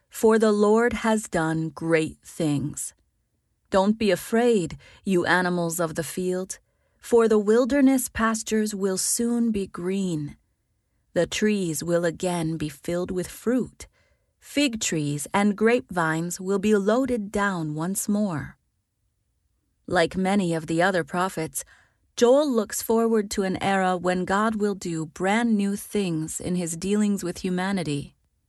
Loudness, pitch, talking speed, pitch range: -24 LUFS, 185 Hz, 135 wpm, 165-215 Hz